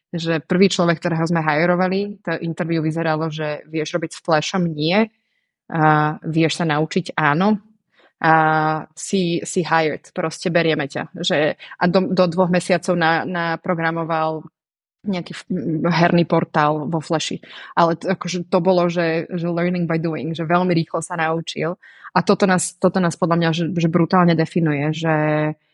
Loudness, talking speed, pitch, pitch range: -19 LUFS, 160 wpm, 170 Hz, 160-180 Hz